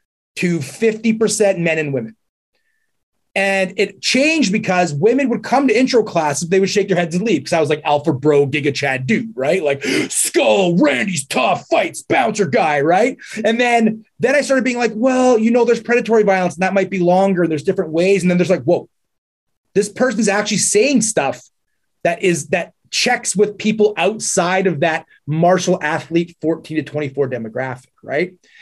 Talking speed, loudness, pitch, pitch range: 185 wpm, -16 LUFS, 190 Hz, 165-225 Hz